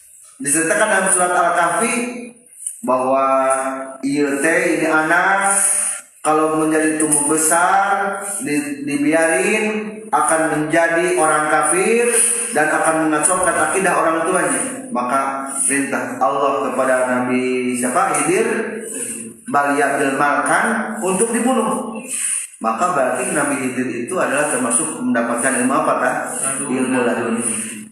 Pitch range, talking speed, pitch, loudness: 135-195 Hz, 100 wpm, 155 Hz, -17 LUFS